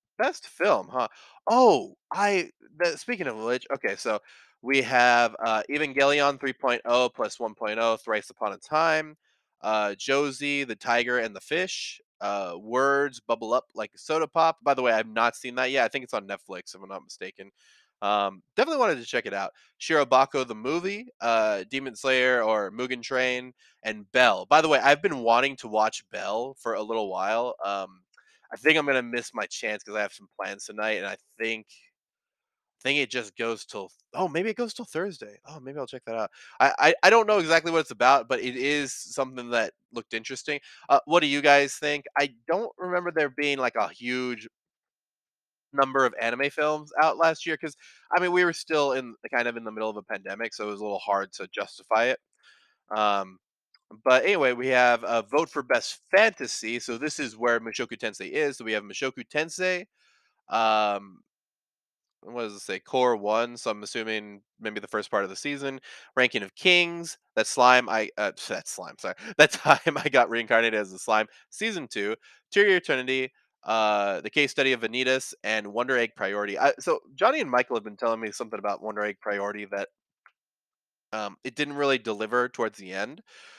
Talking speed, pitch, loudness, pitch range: 195 wpm, 125 Hz, -26 LUFS, 110-145 Hz